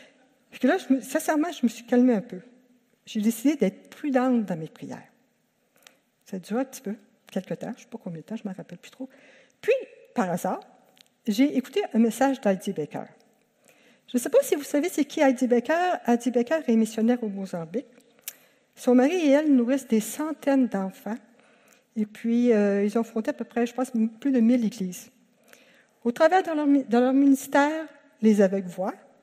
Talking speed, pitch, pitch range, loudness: 200 wpm, 245 Hz, 220-275 Hz, -25 LUFS